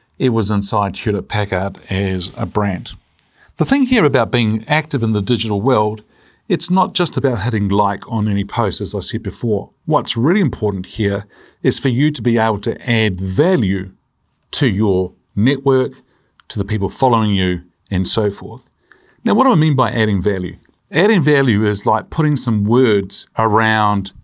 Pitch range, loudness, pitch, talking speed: 100-130 Hz, -16 LUFS, 110 Hz, 175 wpm